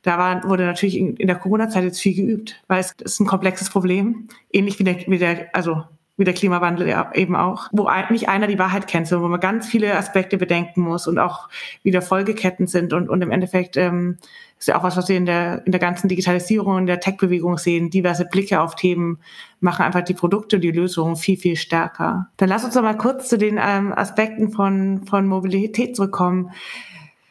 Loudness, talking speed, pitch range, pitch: -19 LUFS, 205 wpm, 175-200 Hz, 185 Hz